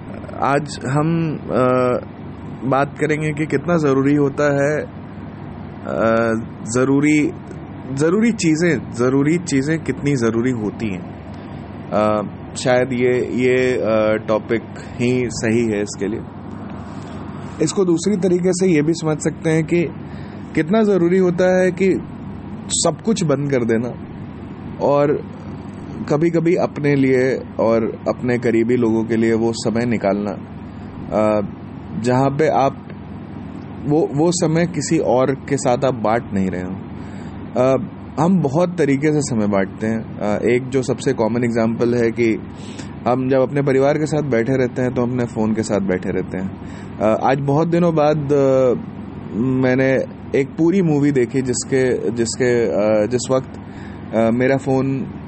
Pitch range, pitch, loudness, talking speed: 110-145 Hz, 125 Hz, -18 LUFS, 130 wpm